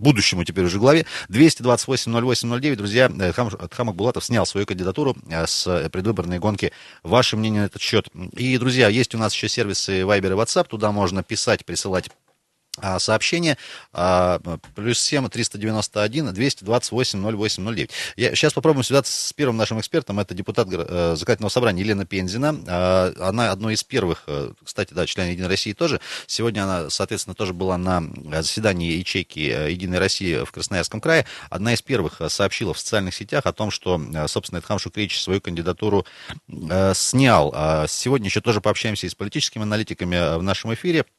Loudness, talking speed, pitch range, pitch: -21 LUFS, 150 wpm, 90-120 Hz, 105 Hz